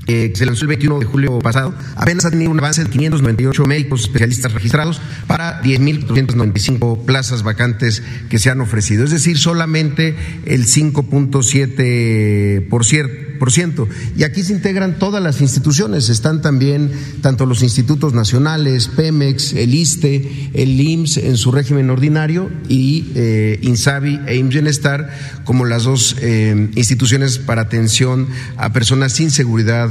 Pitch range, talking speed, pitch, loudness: 120-150 Hz, 145 wpm, 135 Hz, -14 LUFS